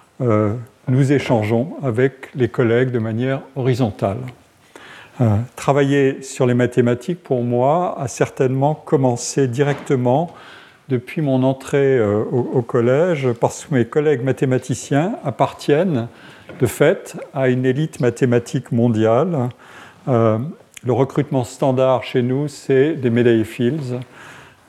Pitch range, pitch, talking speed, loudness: 120-140 Hz, 130 Hz, 120 wpm, -18 LUFS